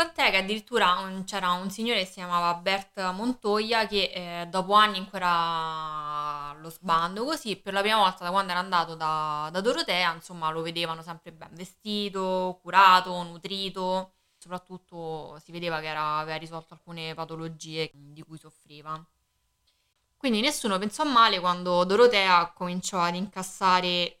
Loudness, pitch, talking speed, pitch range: -26 LUFS, 180 Hz, 145 wpm, 165-195 Hz